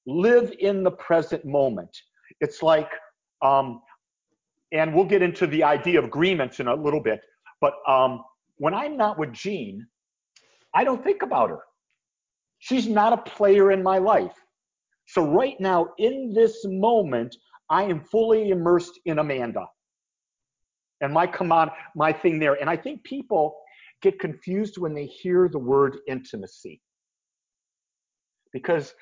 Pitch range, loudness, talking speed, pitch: 150-205 Hz, -23 LUFS, 145 wpm, 175 Hz